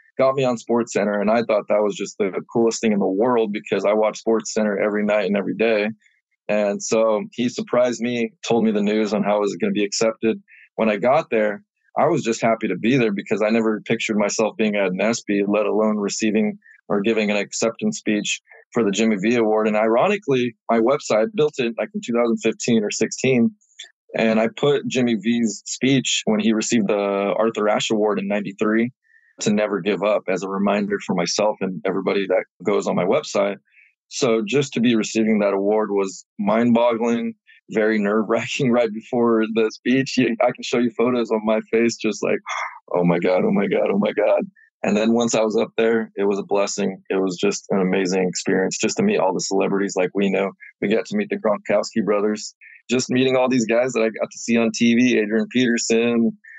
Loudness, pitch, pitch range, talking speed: -20 LUFS, 110 Hz, 105-115 Hz, 210 wpm